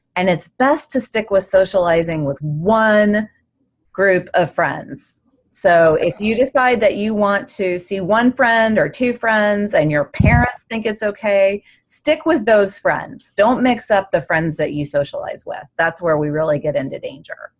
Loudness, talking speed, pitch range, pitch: -17 LUFS, 175 wpm, 165-230 Hz, 205 Hz